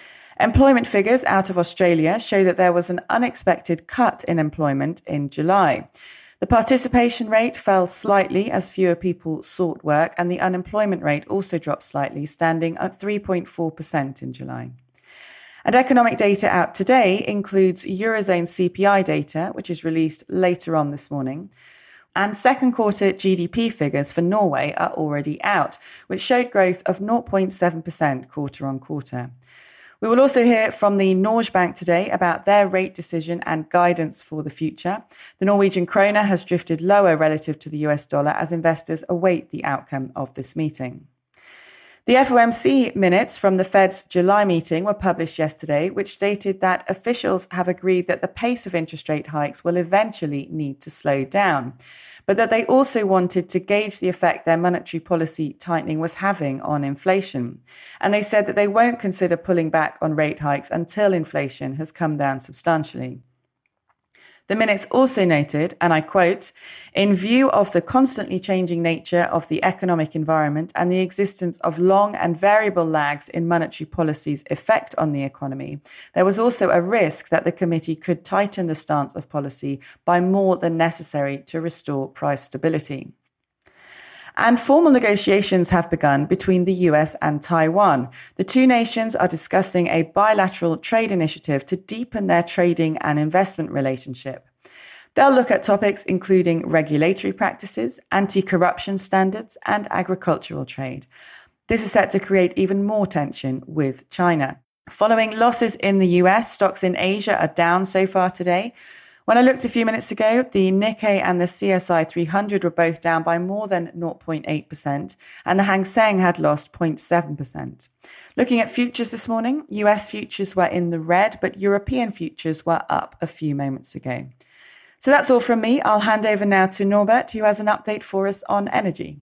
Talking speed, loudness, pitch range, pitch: 165 wpm, -20 LUFS, 160-200 Hz, 180 Hz